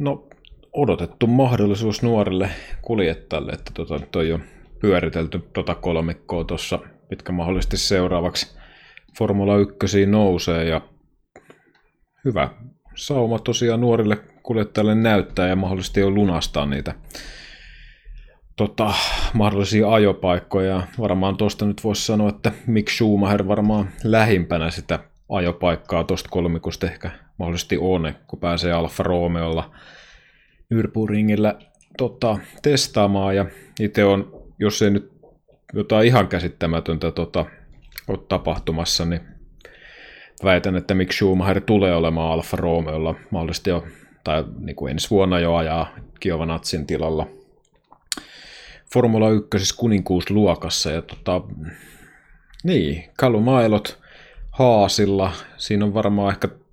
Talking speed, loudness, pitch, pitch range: 110 wpm, -21 LUFS, 95 Hz, 85-105 Hz